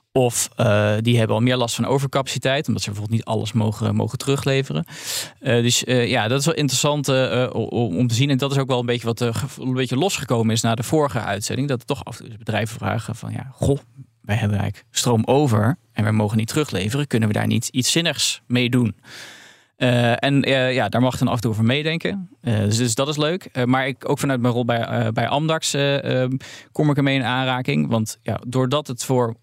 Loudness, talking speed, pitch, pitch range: -21 LUFS, 240 wpm, 125 Hz, 115-135 Hz